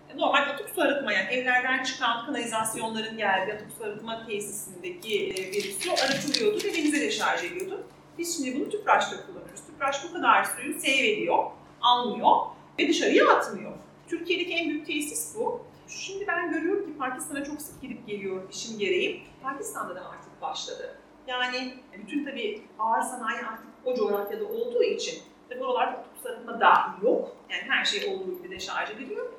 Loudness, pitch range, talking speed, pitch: -27 LUFS, 250-405 Hz, 165 wpm, 315 Hz